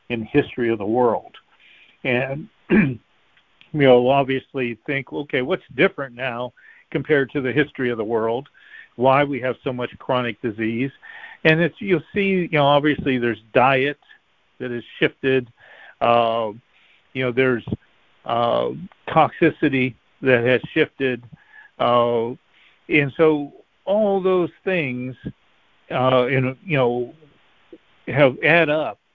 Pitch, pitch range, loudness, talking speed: 130 Hz, 120-150 Hz, -20 LUFS, 130 wpm